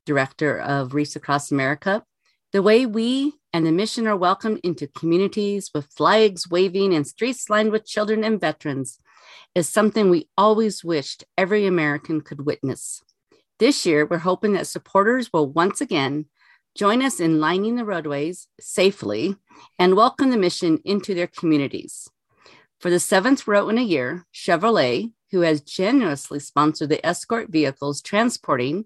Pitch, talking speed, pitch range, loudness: 180 Hz, 150 wpm, 155-215 Hz, -21 LUFS